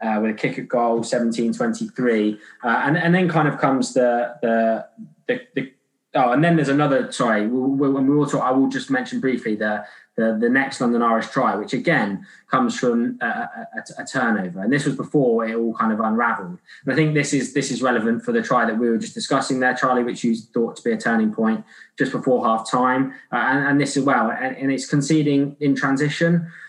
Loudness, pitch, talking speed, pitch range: -20 LUFS, 135 Hz, 225 wpm, 115-150 Hz